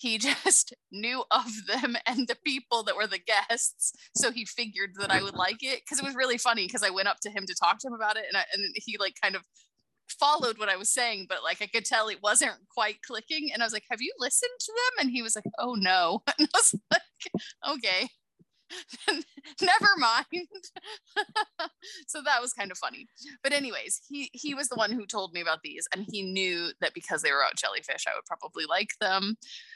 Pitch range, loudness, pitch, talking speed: 210-300 Hz, -28 LUFS, 245 Hz, 225 wpm